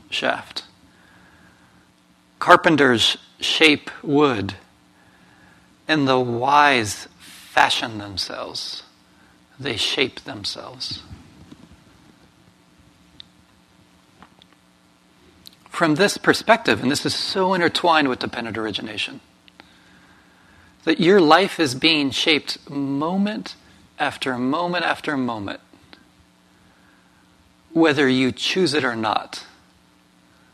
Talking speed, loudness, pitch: 80 wpm, -19 LUFS, 100 Hz